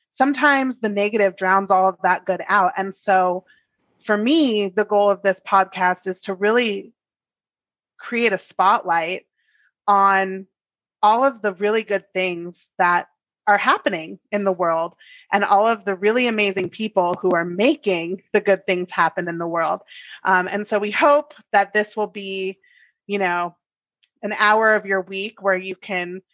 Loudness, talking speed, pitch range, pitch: -20 LUFS, 165 wpm, 185-210 Hz, 195 Hz